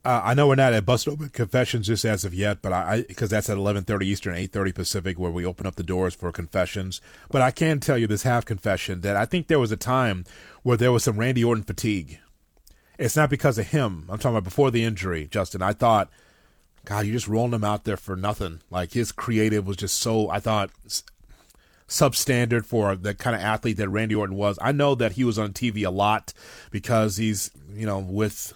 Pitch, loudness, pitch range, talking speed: 110 Hz, -24 LUFS, 100-120 Hz, 230 wpm